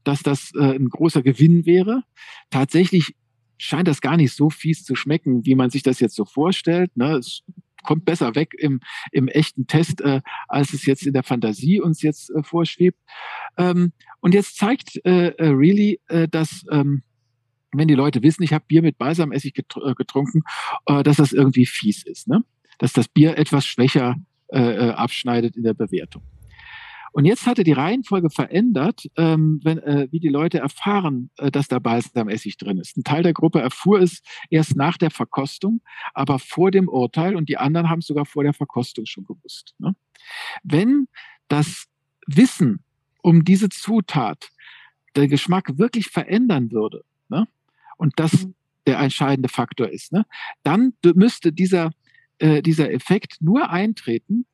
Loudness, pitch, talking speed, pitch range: -19 LUFS, 155 Hz, 160 wpm, 135-180 Hz